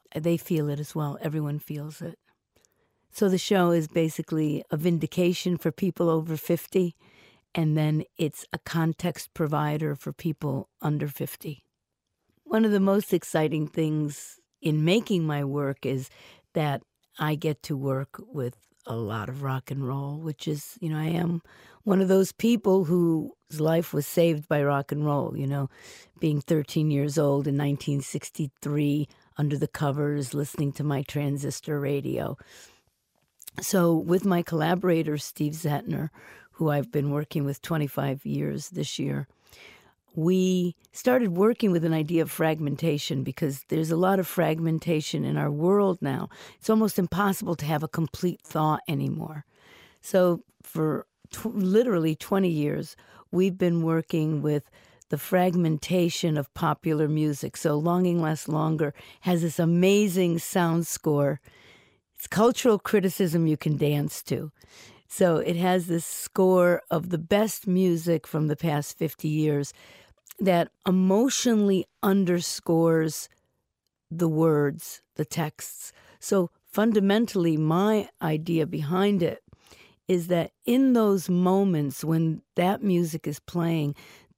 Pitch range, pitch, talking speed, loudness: 150-180 Hz, 160 Hz, 140 wpm, -26 LUFS